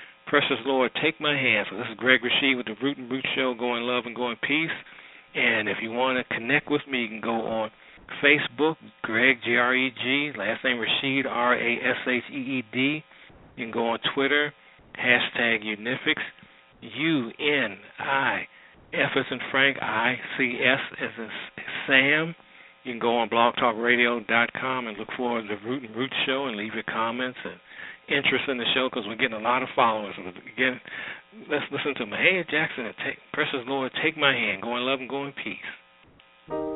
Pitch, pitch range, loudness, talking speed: 125 Hz, 115-135 Hz, -25 LUFS, 170 wpm